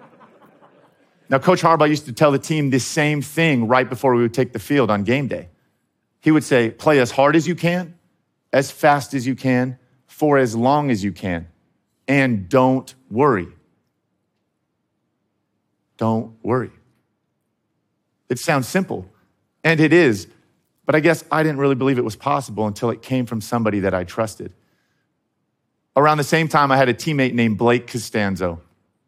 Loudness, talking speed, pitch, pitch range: -19 LUFS, 165 wpm, 130 Hz, 115-145 Hz